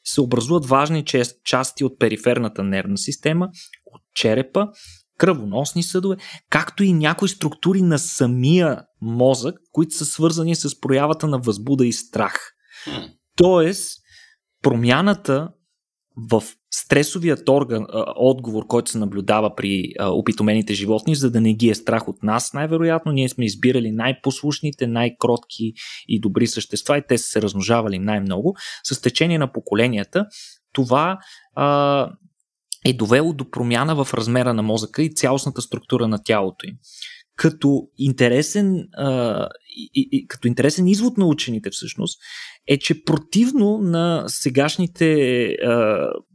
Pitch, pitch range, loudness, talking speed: 135 Hz, 115-165 Hz, -20 LUFS, 120 wpm